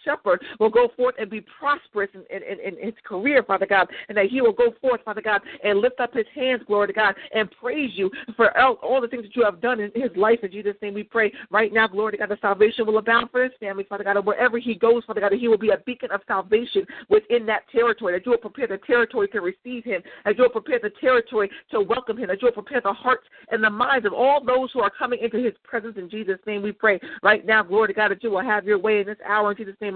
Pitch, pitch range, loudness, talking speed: 220 Hz, 205-250 Hz, -22 LUFS, 280 wpm